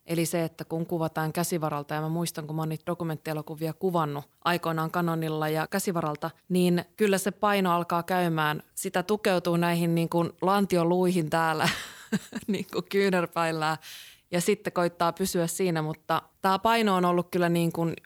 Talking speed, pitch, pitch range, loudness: 155 wpm, 170 Hz, 160-185 Hz, -27 LUFS